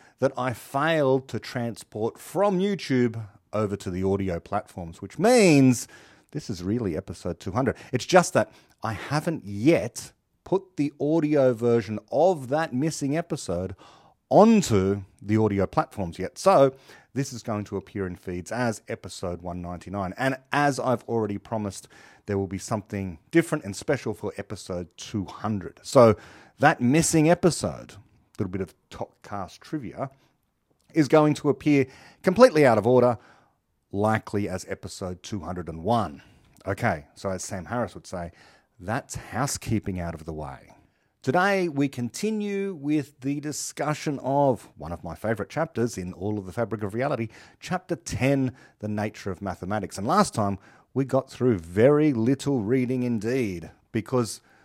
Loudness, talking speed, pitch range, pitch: -25 LUFS, 150 wpm, 100-140 Hz, 115 Hz